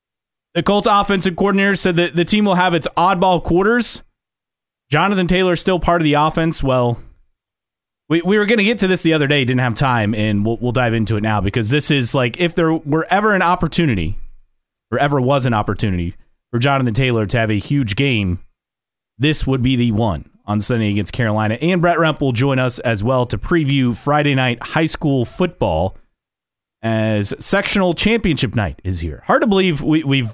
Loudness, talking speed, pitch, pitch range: -16 LUFS, 200 wpm, 135 Hz, 115-175 Hz